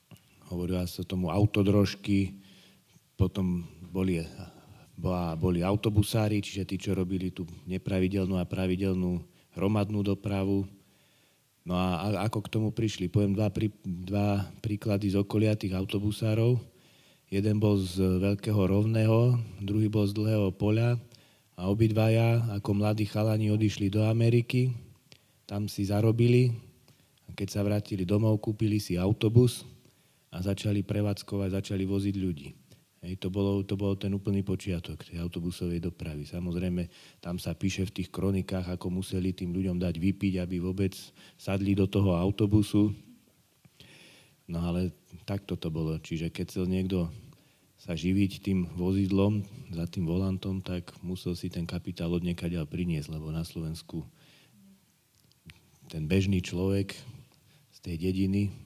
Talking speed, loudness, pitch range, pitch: 135 wpm, -30 LUFS, 90-105 Hz, 95 Hz